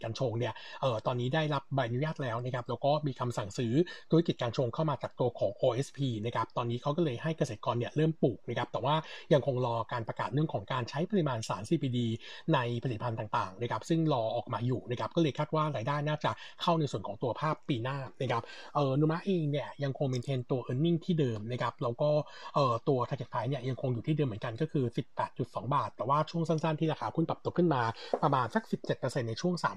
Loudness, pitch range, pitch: -32 LUFS, 125-155 Hz, 140 Hz